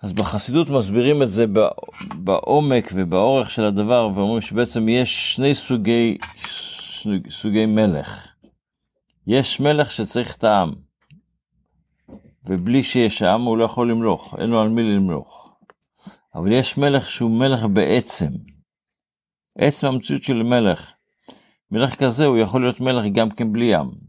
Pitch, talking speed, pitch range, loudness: 115 Hz, 135 wpm, 110-130 Hz, -19 LUFS